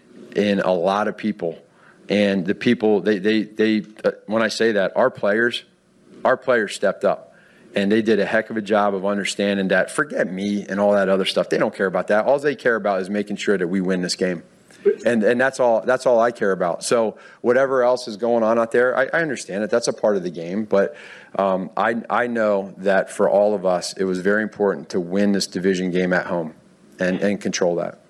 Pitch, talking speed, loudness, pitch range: 100 Hz, 235 wpm, -20 LUFS, 95-110 Hz